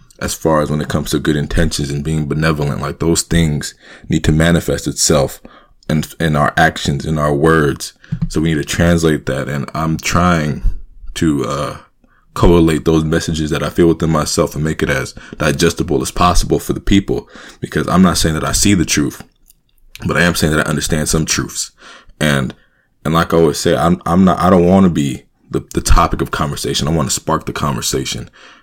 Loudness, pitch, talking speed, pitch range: -15 LUFS, 80 Hz, 210 wpm, 75-85 Hz